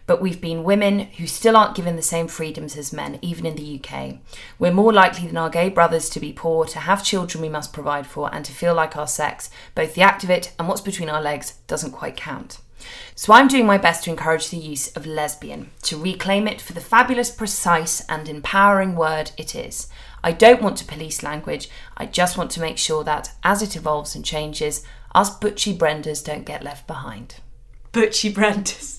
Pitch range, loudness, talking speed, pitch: 150-195 Hz, -20 LUFS, 215 wpm, 165 Hz